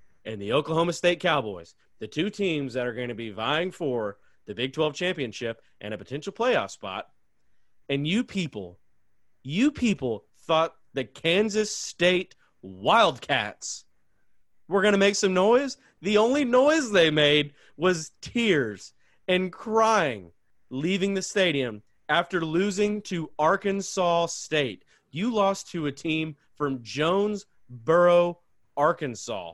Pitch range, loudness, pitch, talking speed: 130-195 Hz, -25 LUFS, 165 Hz, 130 wpm